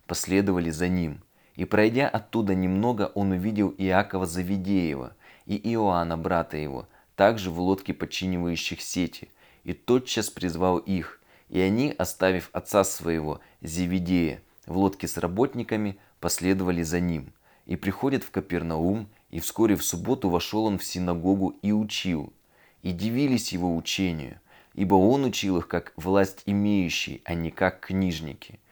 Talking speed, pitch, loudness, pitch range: 140 wpm, 95 Hz, -26 LUFS, 85-100 Hz